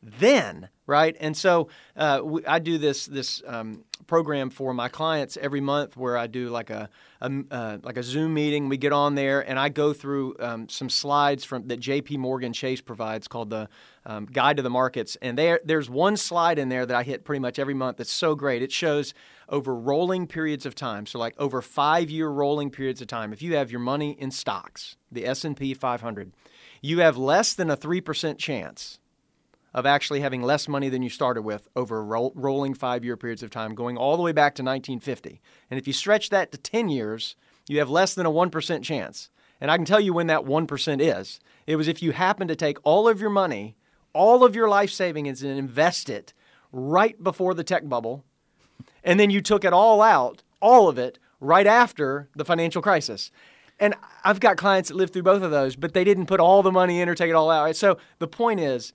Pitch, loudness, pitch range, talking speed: 145 Hz, -23 LUFS, 130-170 Hz, 220 wpm